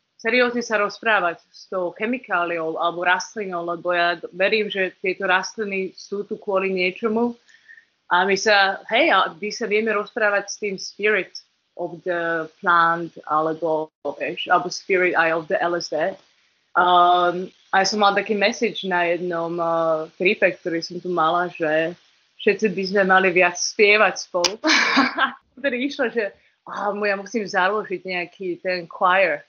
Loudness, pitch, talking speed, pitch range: -21 LUFS, 185 Hz, 150 wpm, 175-210 Hz